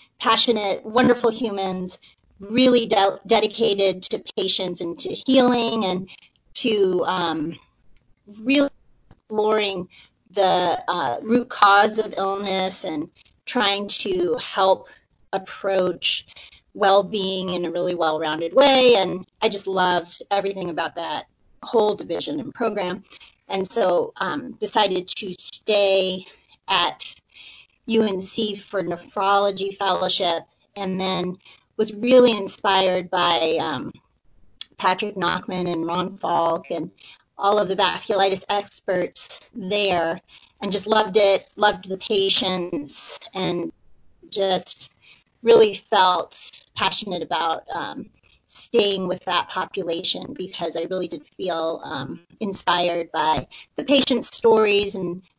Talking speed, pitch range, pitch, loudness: 115 wpm, 180-215 Hz, 195 Hz, -21 LUFS